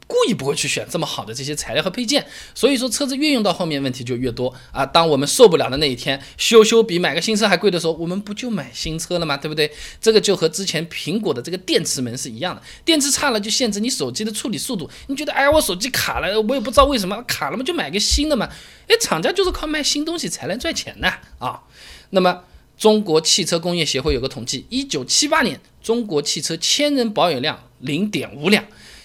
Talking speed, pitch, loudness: 360 characters per minute, 195 Hz, -19 LUFS